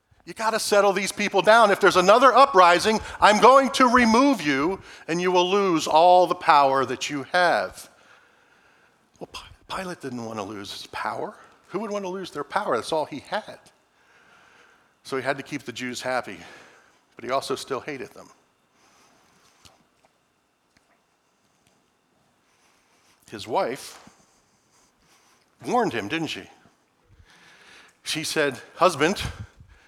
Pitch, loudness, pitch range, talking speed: 180 Hz, -21 LUFS, 140-205 Hz, 130 wpm